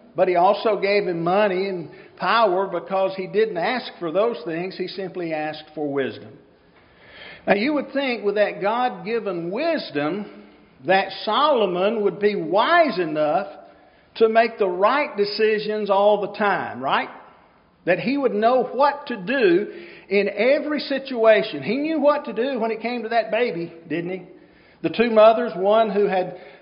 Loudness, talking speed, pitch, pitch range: -21 LUFS, 165 wpm, 210 Hz, 185-245 Hz